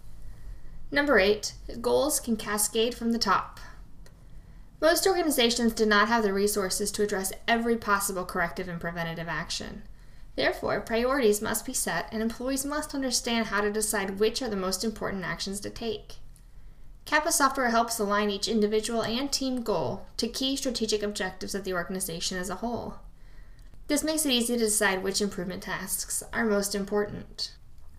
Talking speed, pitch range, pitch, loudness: 160 wpm, 195-235 Hz, 210 Hz, -27 LUFS